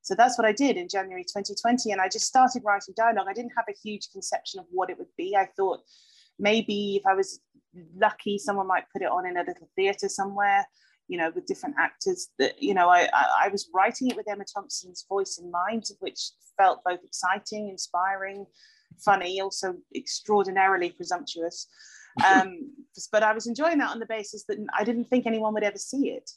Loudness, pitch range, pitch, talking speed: -26 LUFS, 190-245 Hz, 205 Hz, 200 wpm